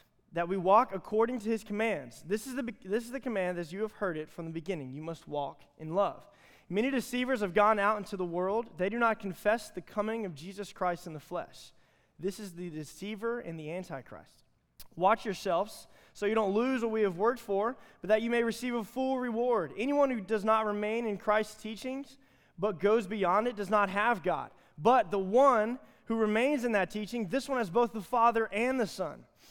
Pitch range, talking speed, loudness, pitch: 185-235 Hz, 220 wpm, -31 LUFS, 210 Hz